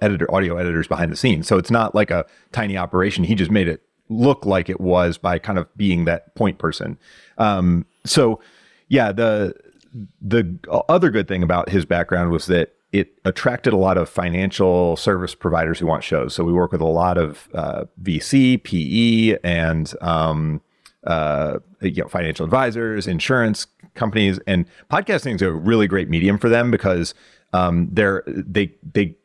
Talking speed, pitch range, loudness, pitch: 175 wpm, 85-105 Hz, -19 LUFS, 95 Hz